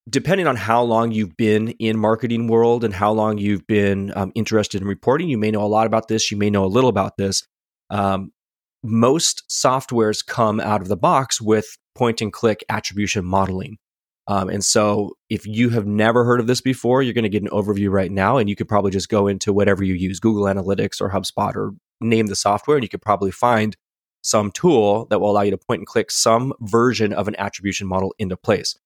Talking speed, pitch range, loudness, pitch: 220 wpm, 100-115 Hz, -19 LUFS, 105 Hz